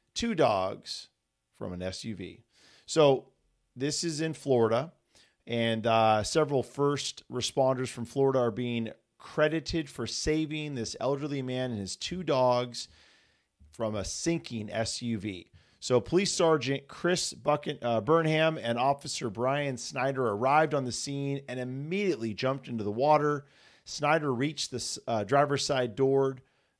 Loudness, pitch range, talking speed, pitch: -29 LUFS, 115-150 Hz, 135 wpm, 130 Hz